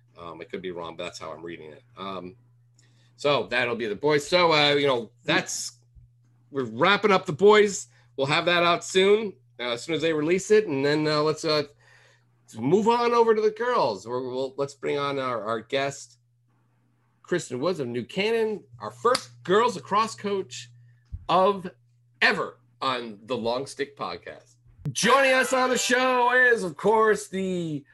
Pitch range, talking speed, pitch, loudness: 120-190 Hz, 185 wpm, 145 Hz, -24 LUFS